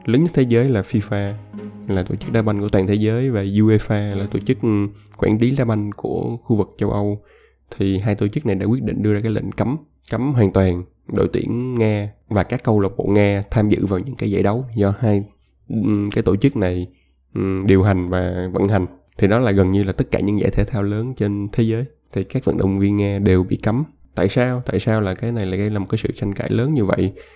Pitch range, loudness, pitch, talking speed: 100-115 Hz, -19 LUFS, 105 Hz, 250 wpm